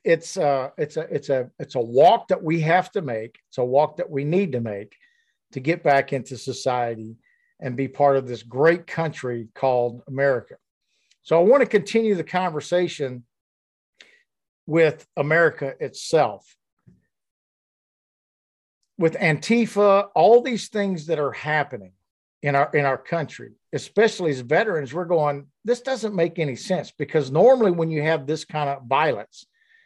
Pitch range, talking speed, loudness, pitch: 130-180 Hz, 155 wpm, -22 LUFS, 150 Hz